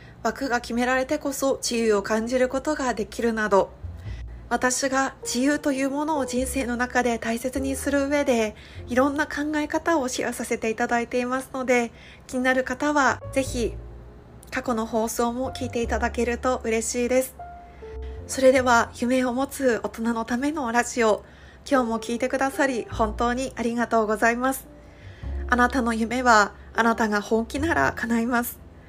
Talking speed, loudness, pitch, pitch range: 320 characters per minute, -24 LUFS, 245 Hz, 225-265 Hz